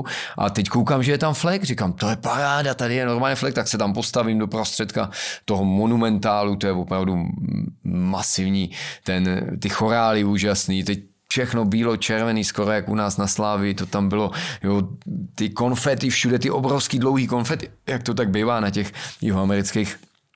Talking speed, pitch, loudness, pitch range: 175 wpm, 110 Hz, -22 LUFS, 100-125 Hz